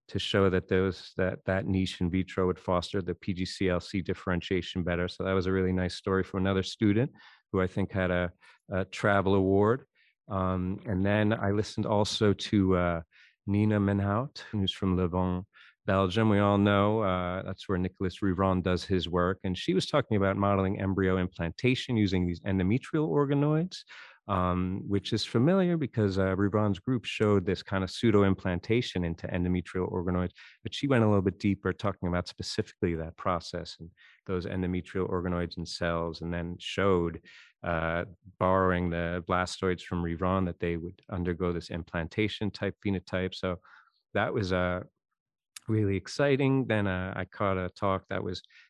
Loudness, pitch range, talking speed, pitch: -29 LUFS, 90-100 Hz, 170 wpm, 95 Hz